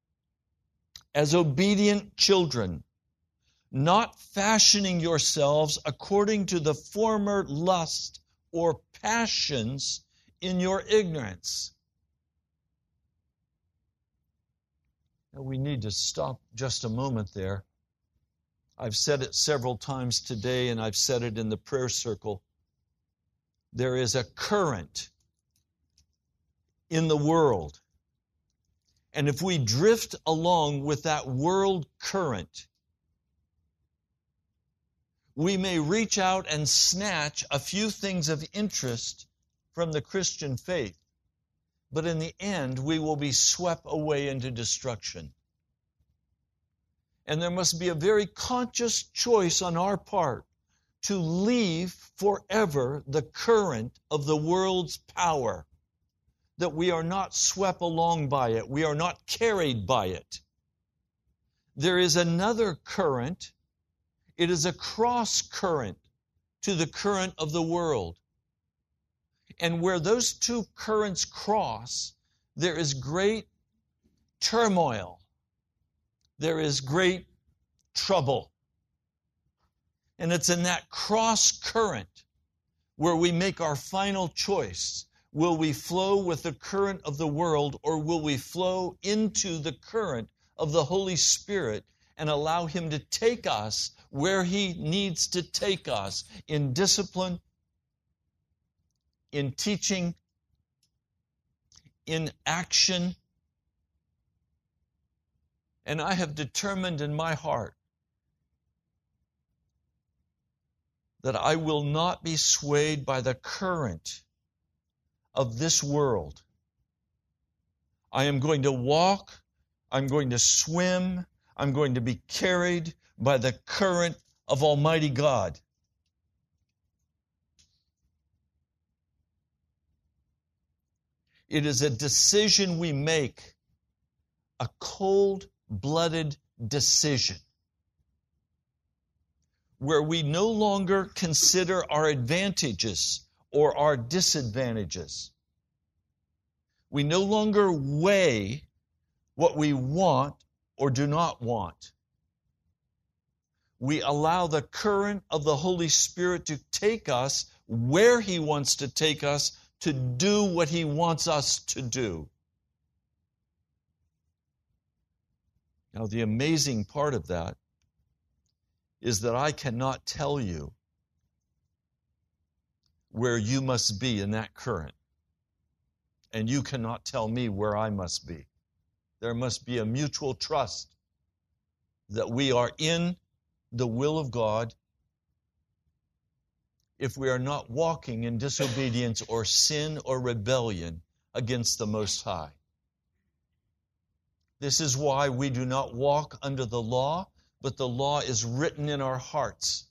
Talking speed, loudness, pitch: 110 wpm, -27 LUFS, 140 Hz